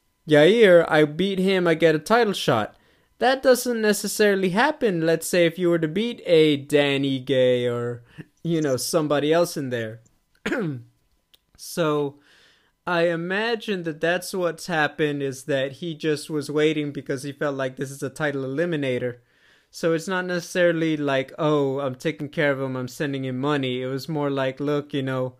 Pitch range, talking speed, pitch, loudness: 135-170 Hz, 175 wpm, 150 Hz, -23 LUFS